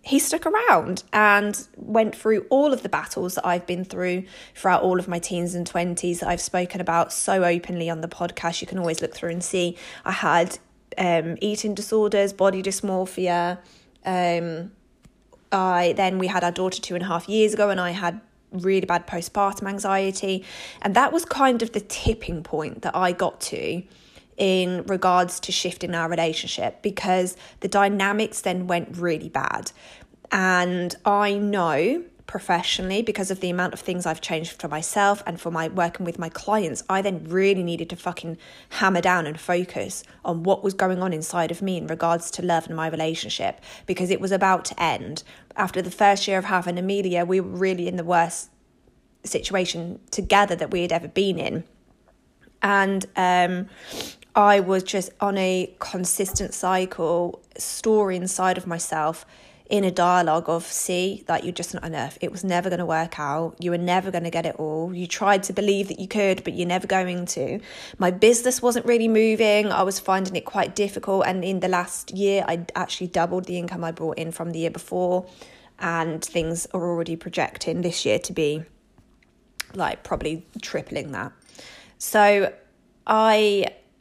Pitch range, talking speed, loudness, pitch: 170-195 Hz, 185 wpm, -23 LUFS, 180 Hz